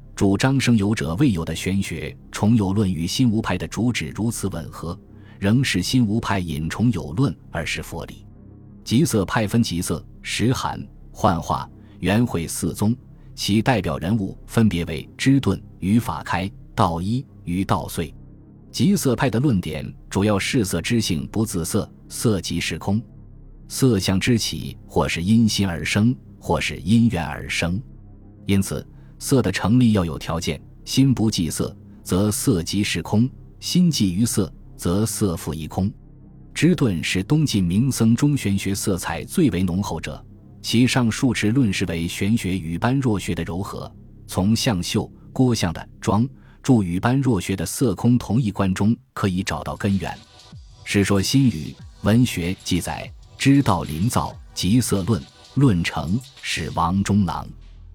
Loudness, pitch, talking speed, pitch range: -22 LUFS, 105 Hz, 220 characters per minute, 90-120 Hz